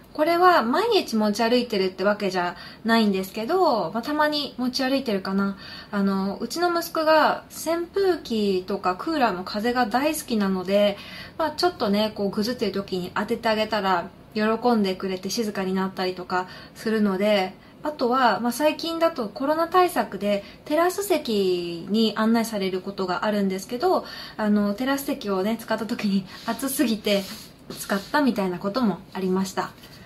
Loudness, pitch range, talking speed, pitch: -24 LUFS, 195-265 Hz, 345 characters per minute, 220 Hz